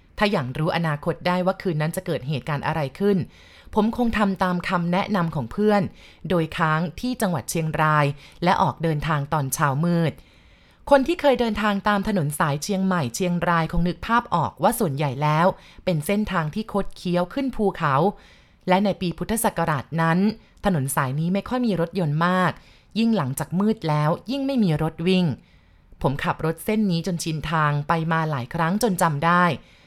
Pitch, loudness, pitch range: 175 Hz, -23 LUFS, 155-200 Hz